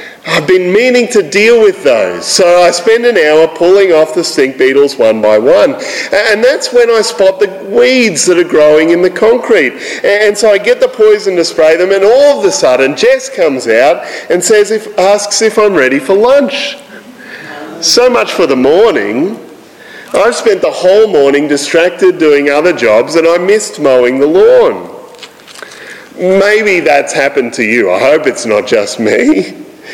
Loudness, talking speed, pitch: -8 LUFS, 190 wpm, 210 Hz